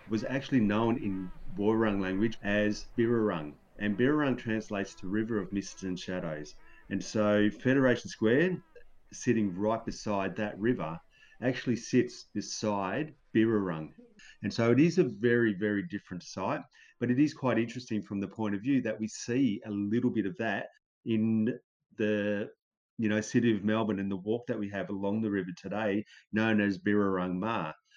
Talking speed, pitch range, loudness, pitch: 165 wpm, 100-115 Hz, -31 LUFS, 105 Hz